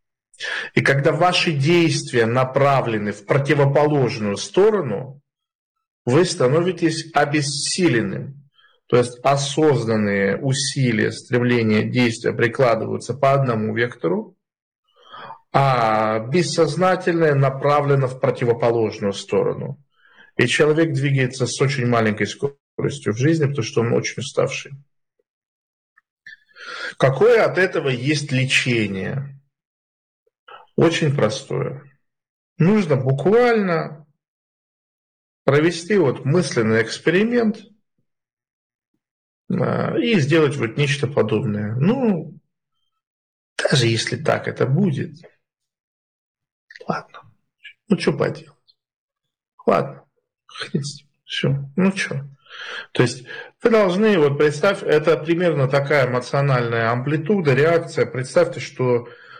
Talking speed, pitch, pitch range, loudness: 90 wpm, 145 Hz, 125-170 Hz, -19 LUFS